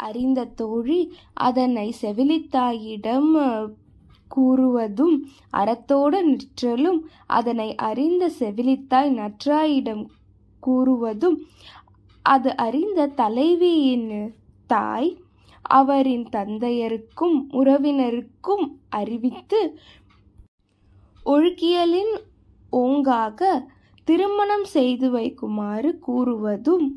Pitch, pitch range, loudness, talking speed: 260 Hz, 230-310 Hz, -22 LUFS, 60 wpm